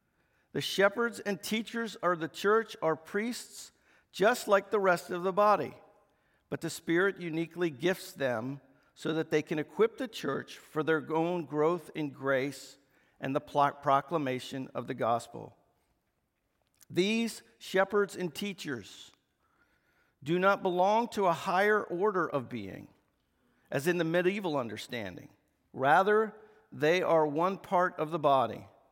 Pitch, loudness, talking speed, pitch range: 175 Hz, -31 LUFS, 140 wpm, 145-200 Hz